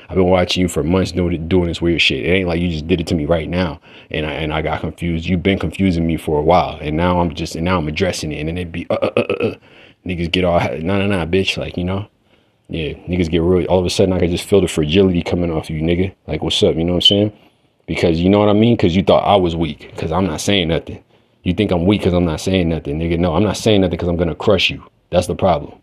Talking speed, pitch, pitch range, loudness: 300 wpm, 90 Hz, 85-95 Hz, -17 LUFS